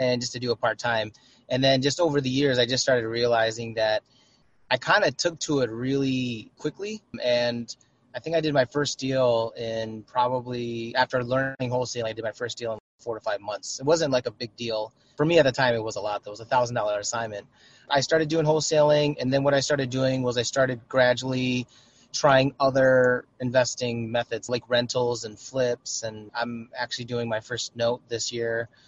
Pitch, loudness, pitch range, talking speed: 125 Hz, -25 LUFS, 115-130 Hz, 210 wpm